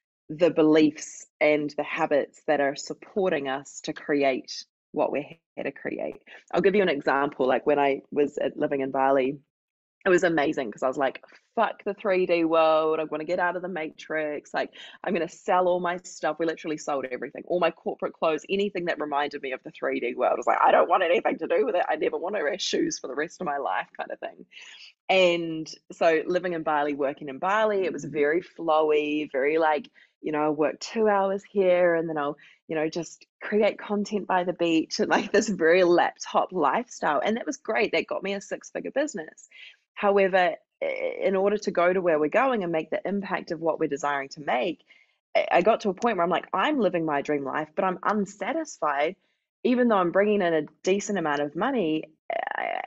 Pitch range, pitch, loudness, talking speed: 150-195 Hz, 170 Hz, -26 LUFS, 215 wpm